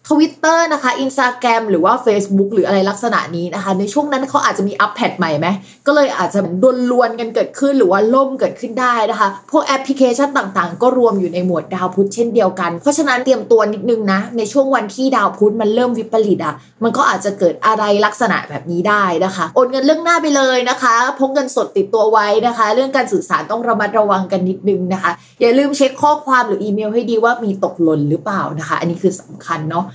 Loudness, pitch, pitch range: -15 LUFS, 225 Hz, 195-260 Hz